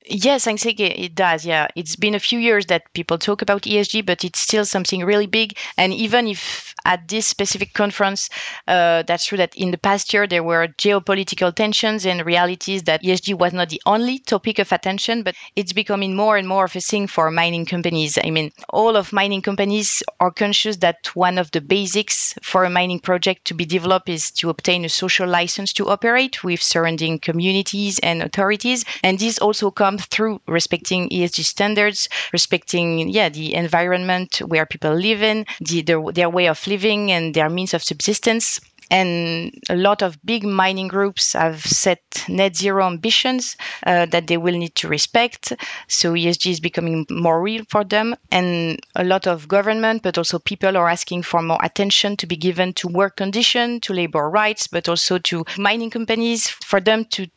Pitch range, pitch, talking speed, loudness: 175-205 Hz, 185 Hz, 190 wpm, -19 LUFS